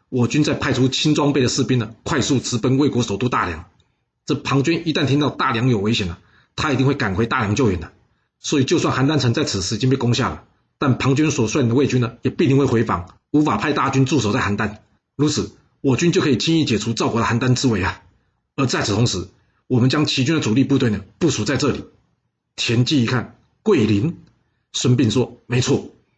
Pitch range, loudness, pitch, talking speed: 110-140 Hz, -19 LUFS, 125 Hz, 325 characters per minute